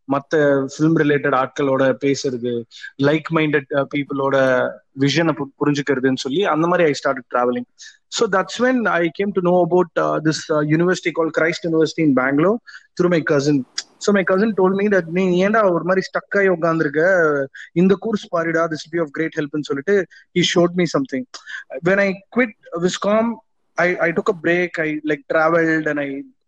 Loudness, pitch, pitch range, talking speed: -19 LUFS, 160 Hz, 145-185 Hz, 155 wpm